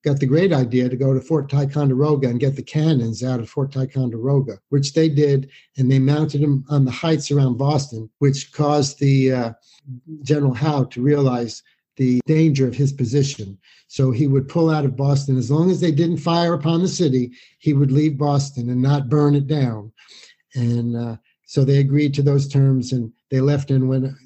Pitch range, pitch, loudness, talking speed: 130-150 Hz, 140 Hz, -19 LUFS, 200 wpm